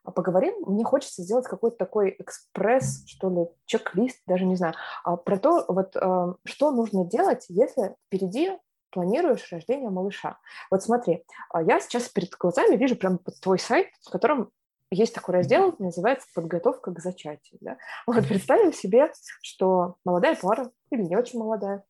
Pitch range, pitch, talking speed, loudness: 180-235 Hz, 190 Hz, 150 wpm, -25 LUFS